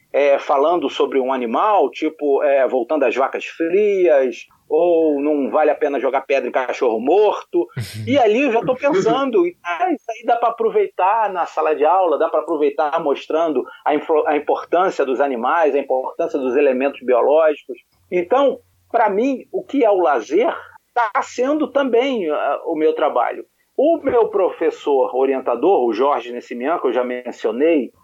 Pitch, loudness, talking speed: 240 Hz, -18 LUFS, 165 wpm